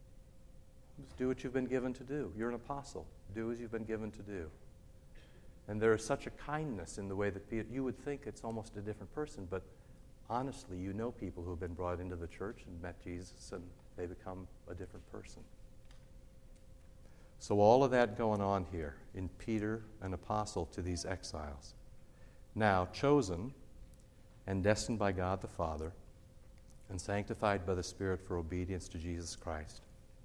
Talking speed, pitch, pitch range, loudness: 175 wpm, 100 Hz, 90-115 Hz, -38 LUFS